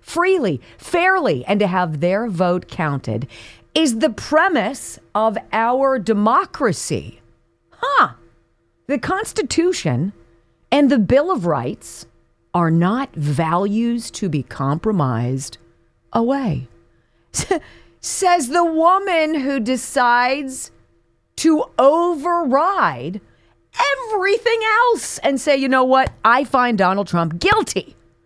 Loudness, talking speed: -18 LUFS, 100 wpm